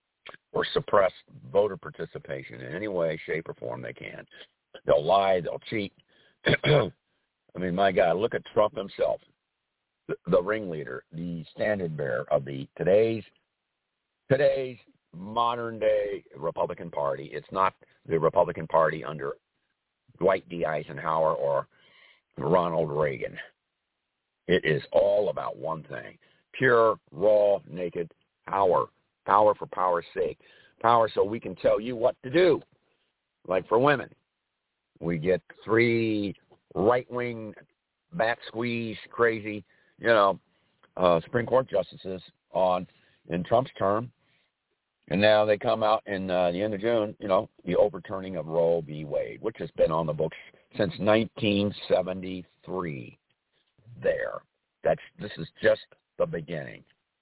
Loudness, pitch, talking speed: -27 LUFS, 110 Hz, 130 wpm